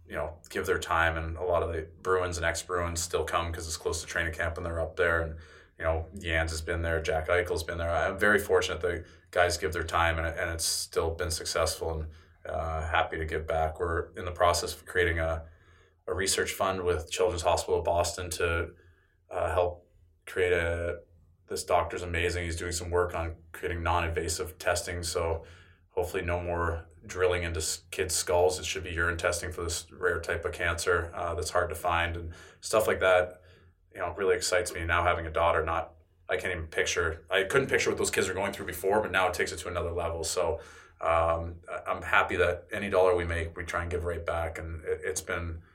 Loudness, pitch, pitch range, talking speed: -30 LUFS, 85 Hz, 80-90 Hz, 220 wpm